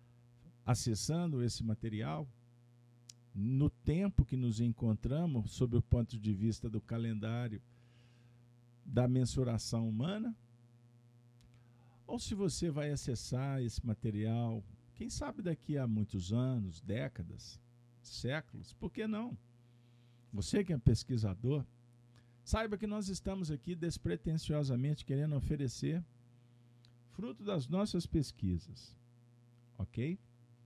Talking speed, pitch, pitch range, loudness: 105 wpm, 120 Hz, 120-140 Hz, -37 LUFS